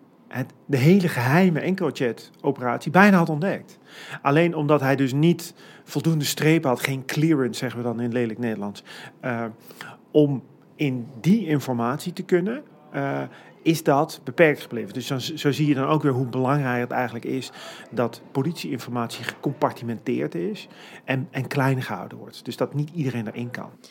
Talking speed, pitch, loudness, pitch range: 165 wpm, 140 Hz, -23 LUFS, 125-160 Hz